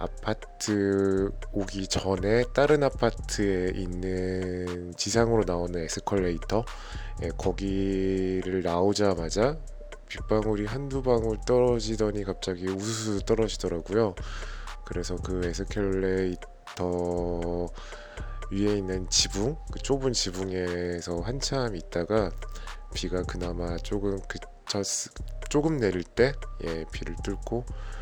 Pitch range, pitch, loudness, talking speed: 90-105 Hz, 100 Hz, -28 LUFS, 235 characters per minute